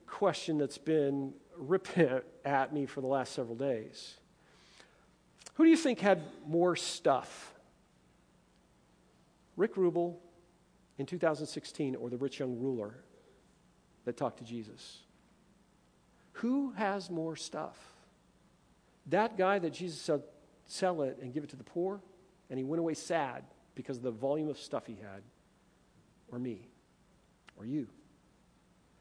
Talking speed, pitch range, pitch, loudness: 135 wpm, 135-180 Hz, 155 Hz, -34 LUFS